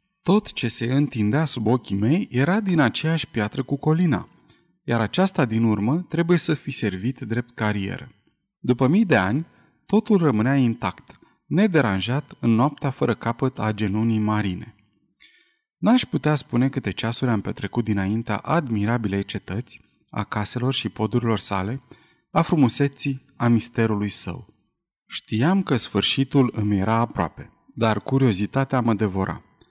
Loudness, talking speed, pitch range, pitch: -22 LUFS, 135 wpm, 105-145 Hz, 120 Hz